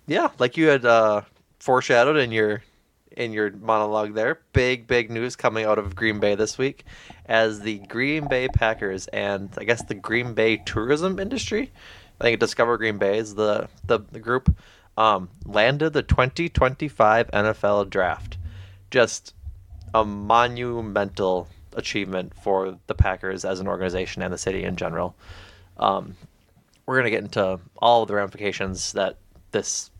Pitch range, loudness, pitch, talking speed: 95-115 Hz, -23 LUFS, 105 Hz, 160 wpm